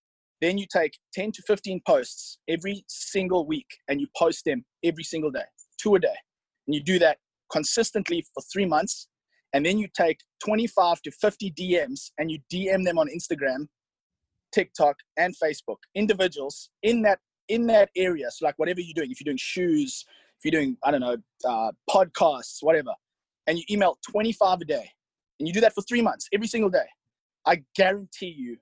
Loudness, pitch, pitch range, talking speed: -26 LUFS, 180 Hz, 155-205 Hz, 185 wpm